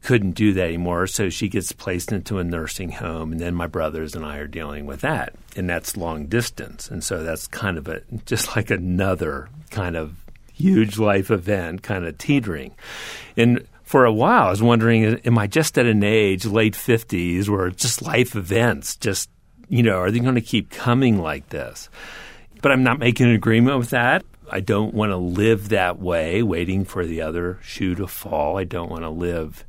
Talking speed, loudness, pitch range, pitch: 200 wpm, -21 LUFS, 90-115 Hz, 100 Hz